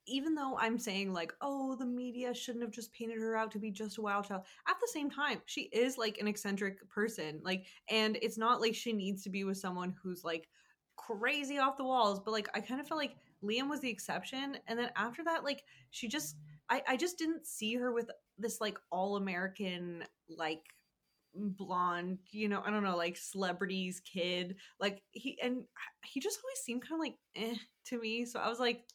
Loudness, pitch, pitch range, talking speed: -38 LUFS, 220 Hz, 195-250 Hz, 215 wpm